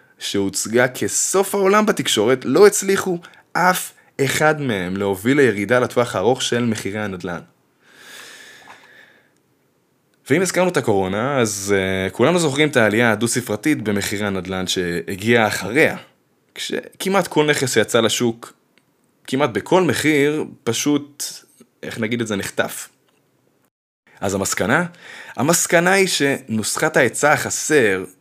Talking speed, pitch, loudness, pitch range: 110 wpm, 120 Hz, -18 LUFS, 100-155 Hz